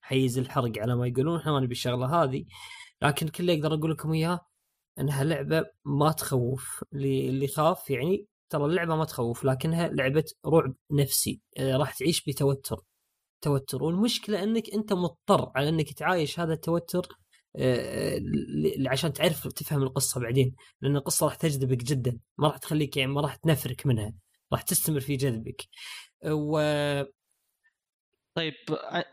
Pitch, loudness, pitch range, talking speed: 145 Hz, -28 LUFS, 135-165 Hz, 145 wpm